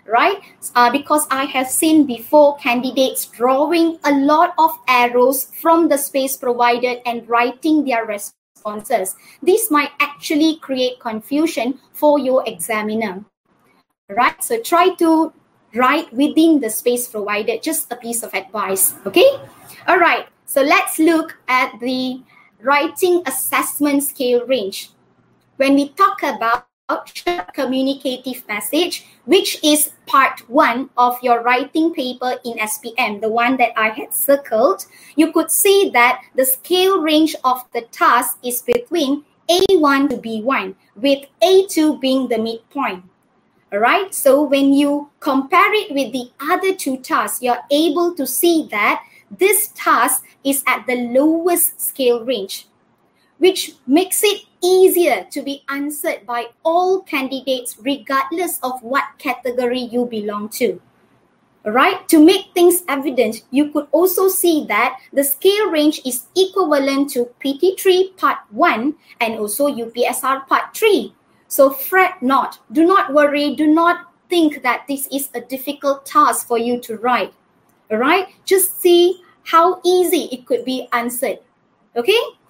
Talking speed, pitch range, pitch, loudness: 140 wpm, 245-330 Hz, 275 Hz, -16 LUFS